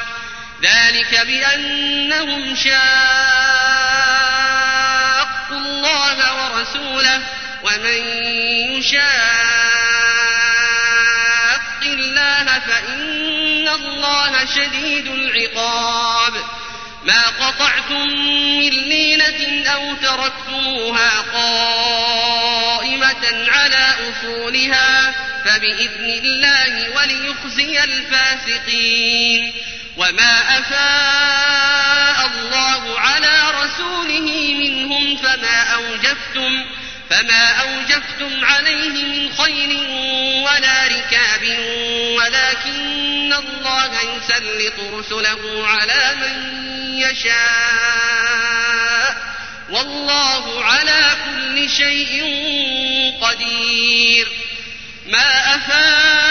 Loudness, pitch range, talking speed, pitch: -14 LUFS, 235-285 Hz, 60 wpm, 265 Hz